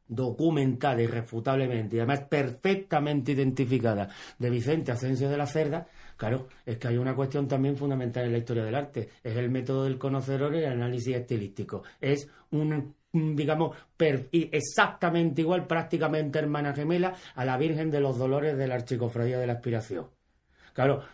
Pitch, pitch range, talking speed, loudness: 135 Hz, 125-155 Hz, 160 wpm, -29 LUFS